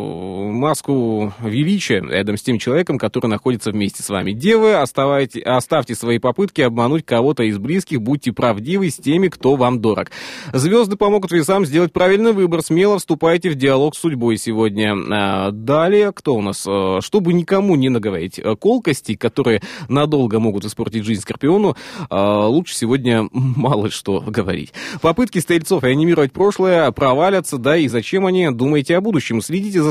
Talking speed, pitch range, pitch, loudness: 150 wpm, 115-175 Hz, 135 Hz, -17 LUFS